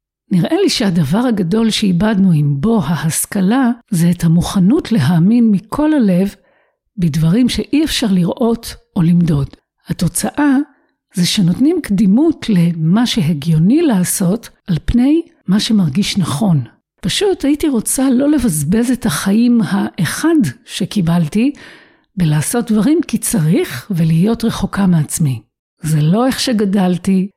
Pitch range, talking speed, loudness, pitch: 175-245 Hz, 115 wpm, -14 LUFS, 205 Hz